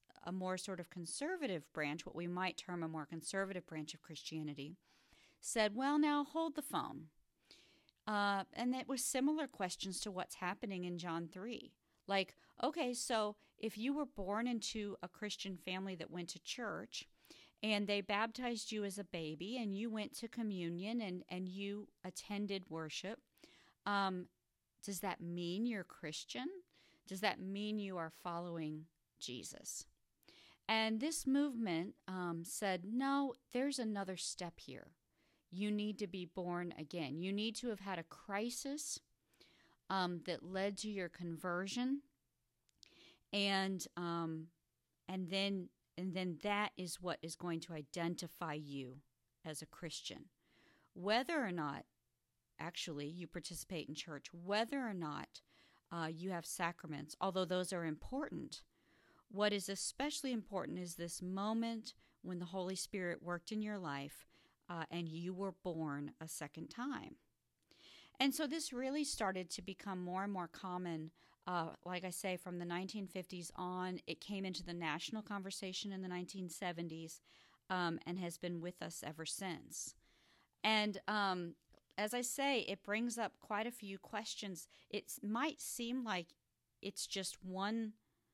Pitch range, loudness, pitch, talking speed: 170-210 Hz, -42 LUFS, 185 Hz, 150 wpm